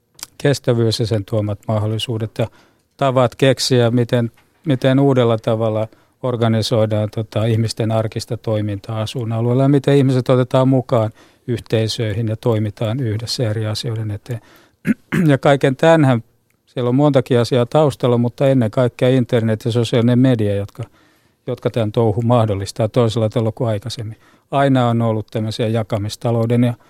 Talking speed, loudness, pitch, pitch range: 135 wpm, -17 LUFS, 120 Hz, 110-130 Hz